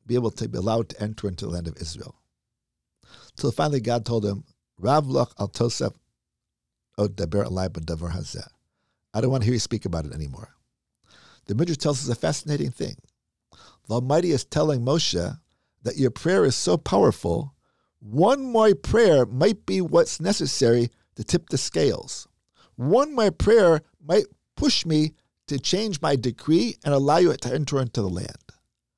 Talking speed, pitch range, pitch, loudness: 155 wpm, 100-155 Hz, 125 Hz, -23 LUFS